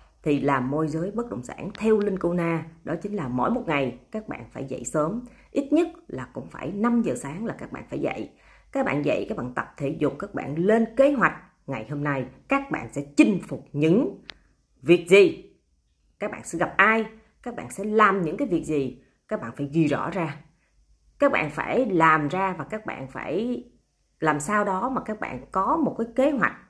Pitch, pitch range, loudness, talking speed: 175 Hz, 145-220 Hz, -25 LUFS, 220 wpm